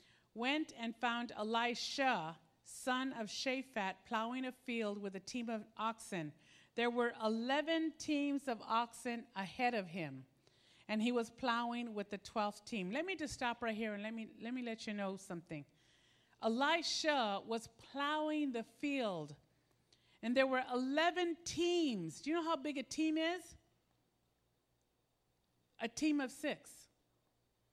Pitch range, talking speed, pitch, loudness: 195-265 Hz, 150 wpm, 230 Hz, -39 LUFS